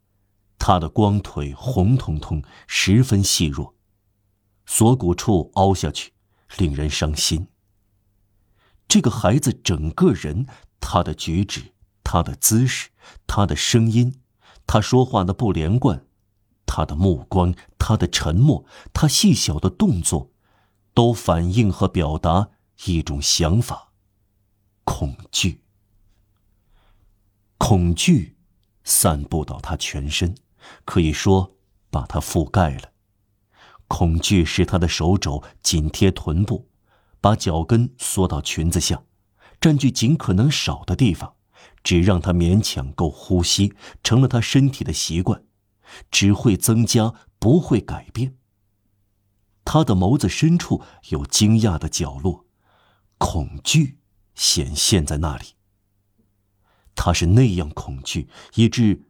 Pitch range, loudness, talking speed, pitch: 85-105 Hz, -20 LUFS, 170 characters per minute, 100 Hz